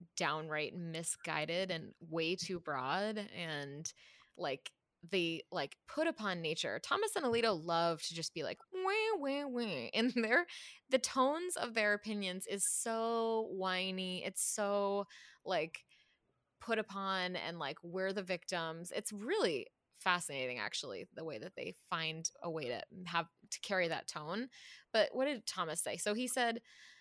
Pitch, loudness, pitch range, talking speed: 190 Hz, -38 LUFS, 170-235 Hz, 155 wpm